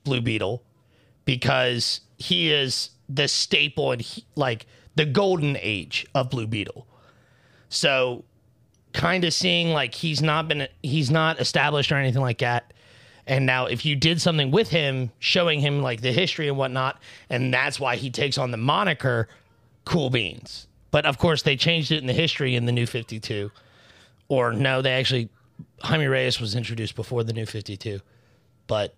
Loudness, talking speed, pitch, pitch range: -23 LUFS, 175 wpm, 130 Hz, 120-150 Hz